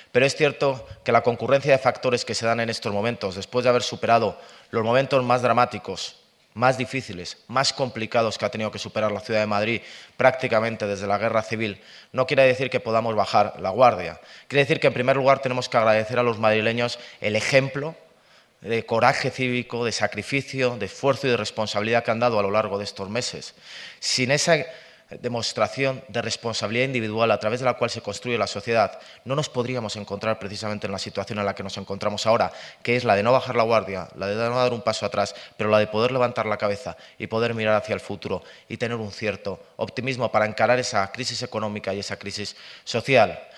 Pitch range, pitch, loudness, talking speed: 105-125 Hz, 115 Hz, -23 LUFS, 210 wpm